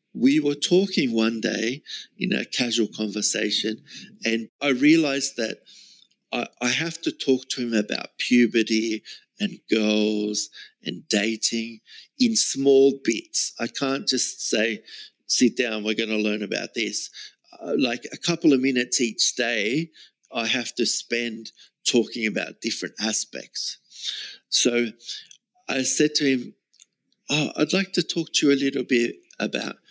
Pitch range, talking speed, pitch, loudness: 110-145 Hz, 145 wpm, 125 Hz, -23 LUFS